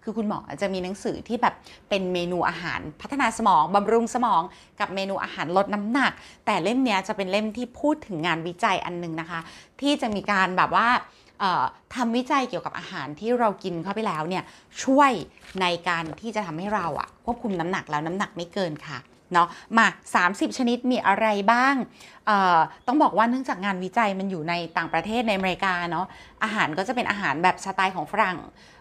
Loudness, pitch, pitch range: -24 LUFS, 200 Hz, 175-235 Hz